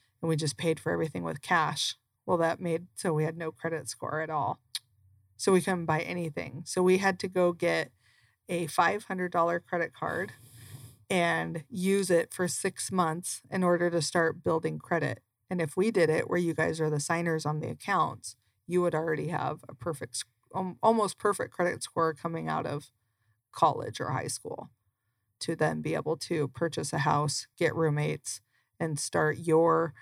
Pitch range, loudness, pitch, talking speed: 130-175 Hz, -30 LUFS, 160 Hz, 180 wpm